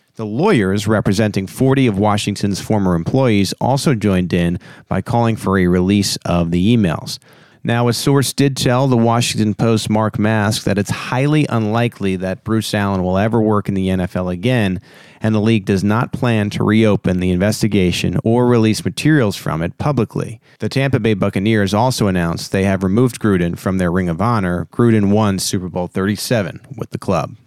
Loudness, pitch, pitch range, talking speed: -16 LUFS, 105 Hz, 95-120 Hz, 180 wpm